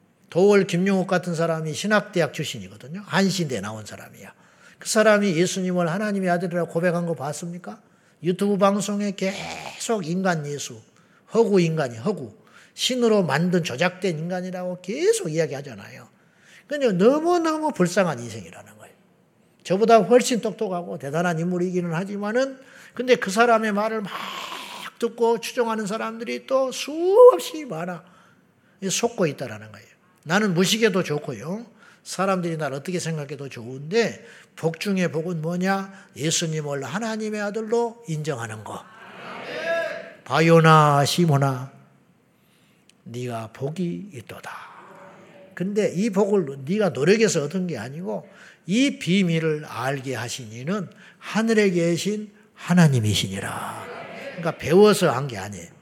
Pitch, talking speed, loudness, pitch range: 180 Hz, 300 characters per minute, -22 LUFS, 160-210 Hz